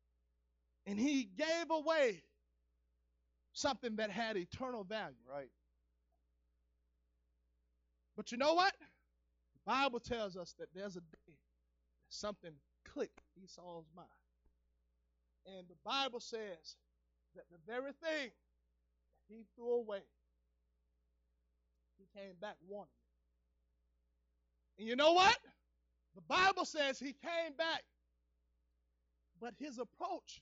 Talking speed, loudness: 115 wpm, -38 LUFS